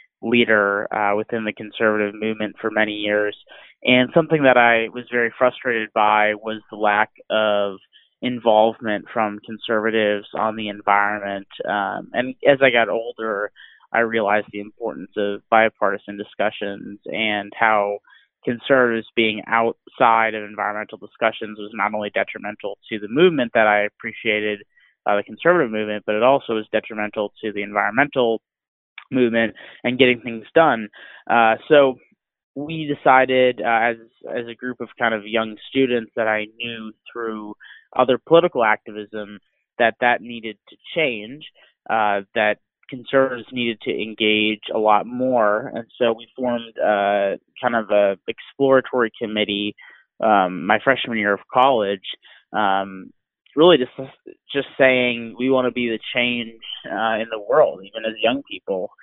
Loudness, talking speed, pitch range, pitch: -20 LUFS, 145 wpm, 105-120 Hz, 110 Hz